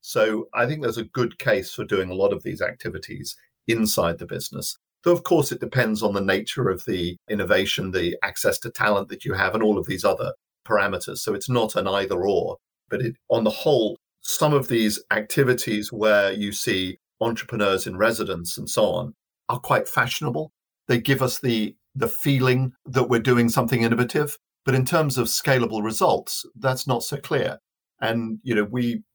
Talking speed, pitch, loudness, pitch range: 190 wpm, 120 Hz, -23 LUFS, 110-135 Hz